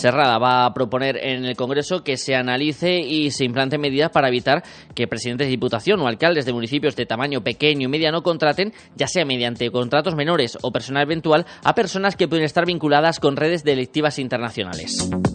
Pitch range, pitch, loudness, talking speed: 125-155 Hz, 145 Hz, -20 LUFS, 190 wpm